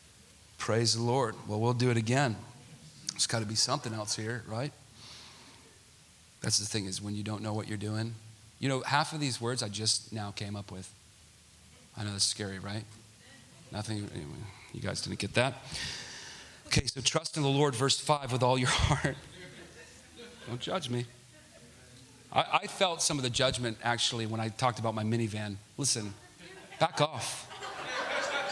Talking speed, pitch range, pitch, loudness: 175 wpm, 105-130 Hz, 115 Hz, -31 LUFS